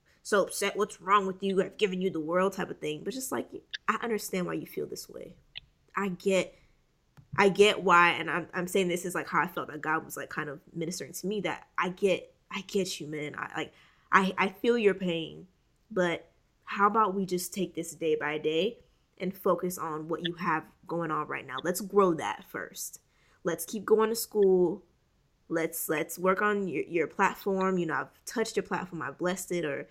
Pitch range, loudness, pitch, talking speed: 165-200 Hz, -30 LUFS, 185 Hz, 215 wpm